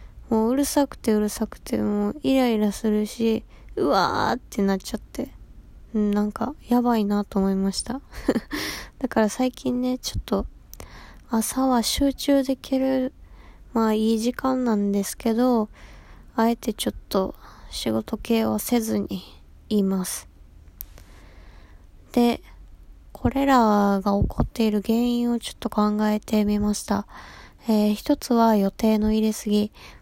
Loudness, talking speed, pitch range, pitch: -24 LUFS, 260 characters per minute, 200-245 Hz, 220 Hz